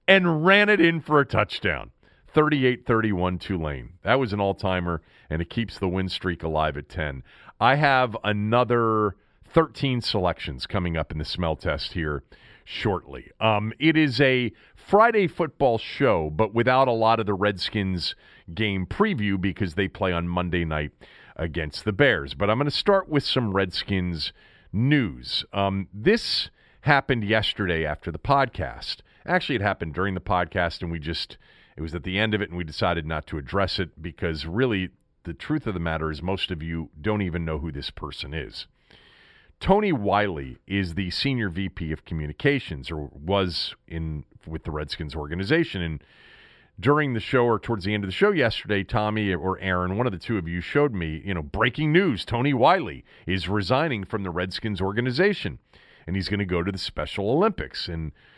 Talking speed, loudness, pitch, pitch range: 185 wpm, -24 LUFS, 95 Hz, 85-115 Hz